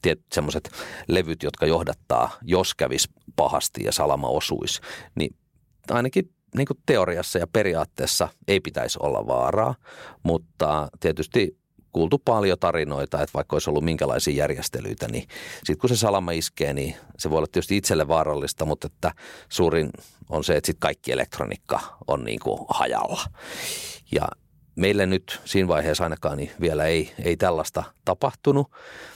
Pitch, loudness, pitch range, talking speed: 95 Hz, -25 LUFS, 80-120 Hz, 145 wpm